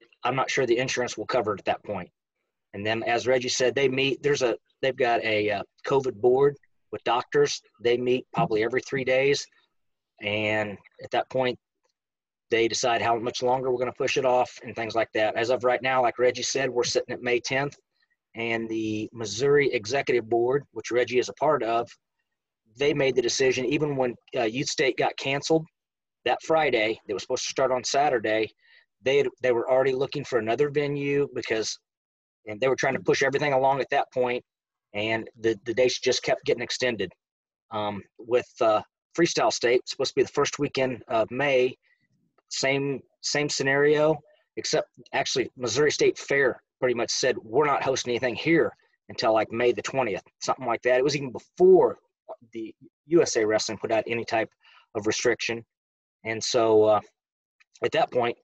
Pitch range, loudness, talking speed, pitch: 115-150 Hz, -25 LUFS, 185 wpm, 130 Hz